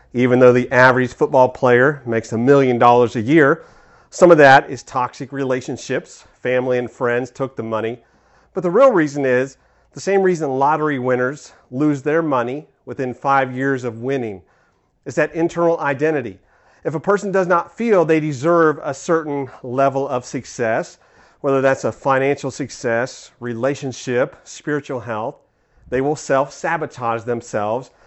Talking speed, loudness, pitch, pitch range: 155 wpm, -18 LUFS, 135 Hz, 125-150 Hz